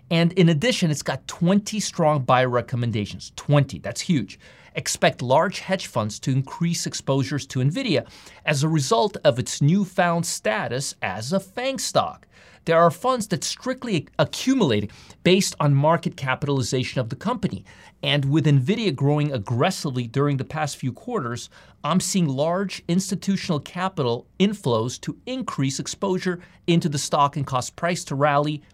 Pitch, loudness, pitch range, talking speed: 155 Hz, -23 LUFS, 130-185 Hz, 150 wpm